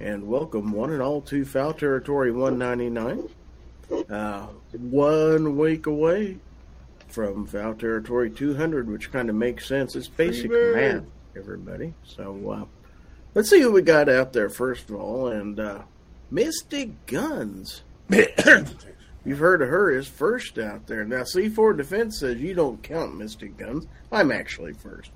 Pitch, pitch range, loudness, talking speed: 125 Hz, 105-155 Hz, -23 LUFS, 150 wpm